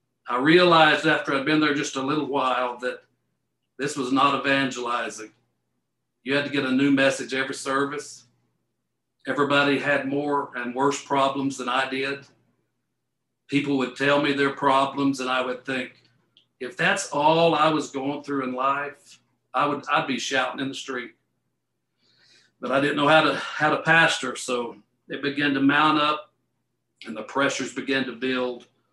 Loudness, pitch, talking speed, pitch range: -23 LUFS, 135 Hz, 170 wpm, 130-145 Hz